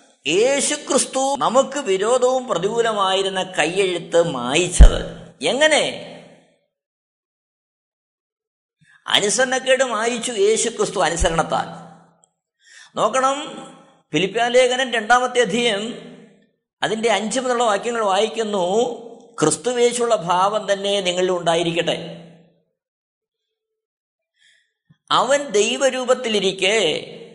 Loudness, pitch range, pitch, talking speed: -19 LUFS, 205-270 Hz, 240 Hz, 60 wpm